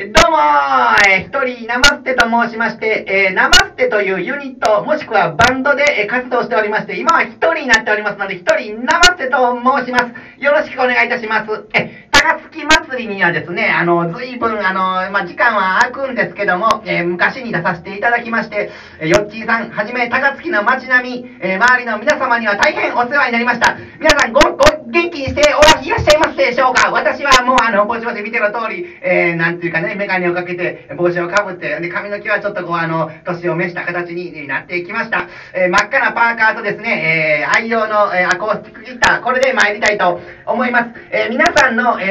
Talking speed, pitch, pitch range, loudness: 435 characters per minute, 230 Hz, 195-265 Hz, -14 LUFS